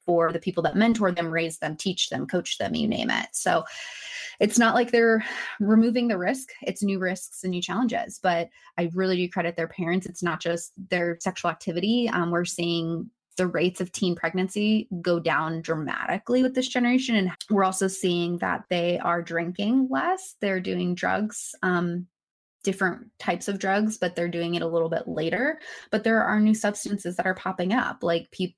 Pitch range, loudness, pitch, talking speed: 175-220 Hz, -26 LUFS, 185 Hz, 195 wpm